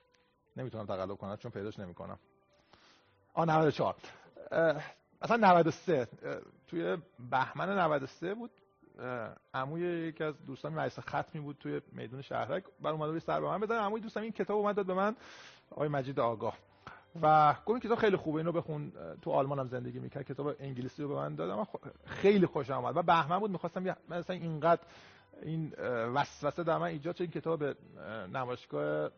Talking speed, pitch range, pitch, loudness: 170 wpm, 130-175 Hz, 155 Hz, -34 LUFS